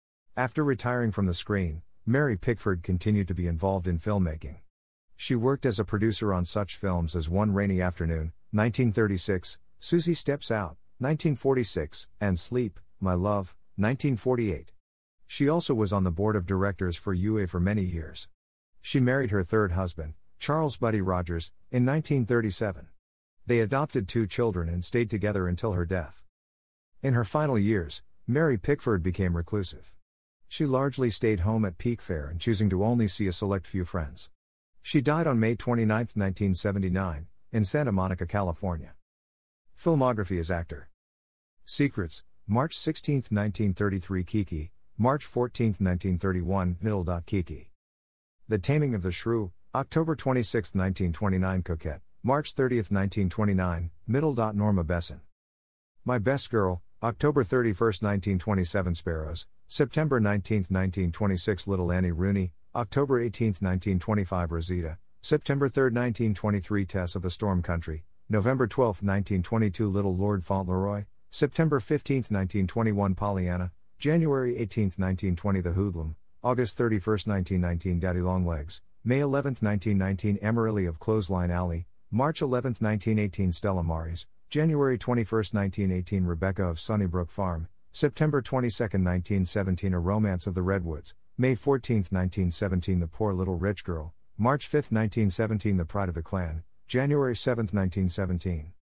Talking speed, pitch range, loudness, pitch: 135 wpm, 90-115 Hz, -28 LUFS, 100 Hz